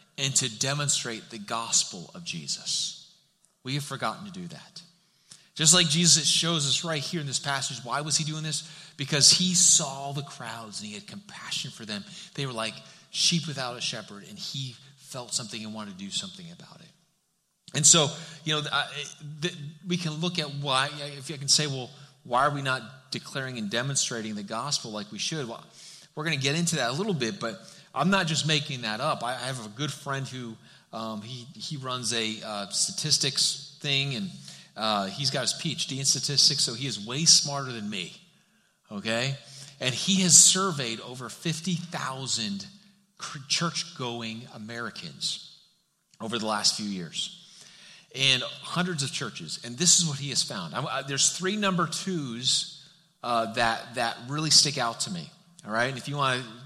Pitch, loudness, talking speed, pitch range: 145 Hz, -25 LUFS, 185 wpm, 130-170 Hz